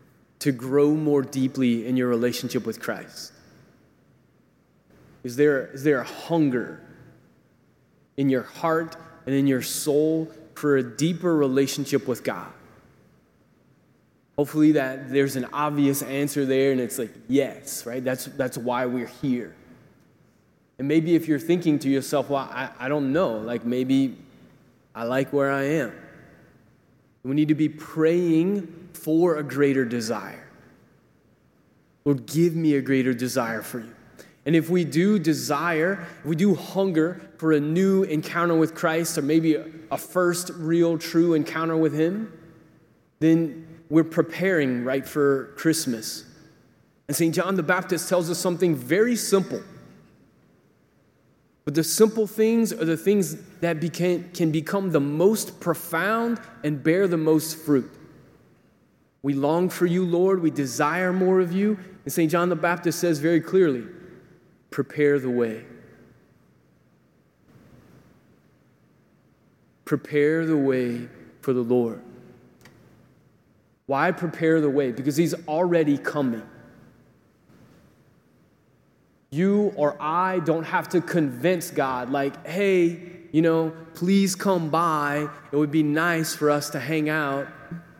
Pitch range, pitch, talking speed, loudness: 140-170 Hz, 155 Hz, 135 wpm, -24 LUFS